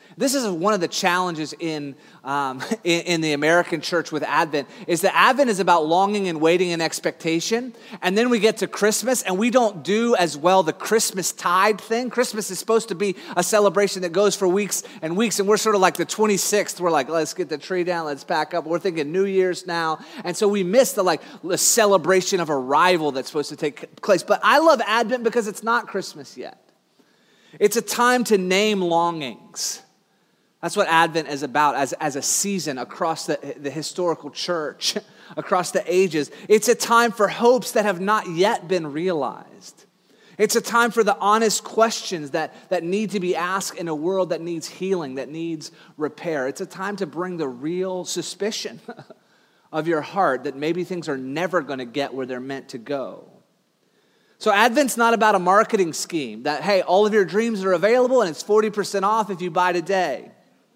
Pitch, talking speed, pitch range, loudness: 185 Hz, 200 wpm, 165-215 Hz, -21 LUFS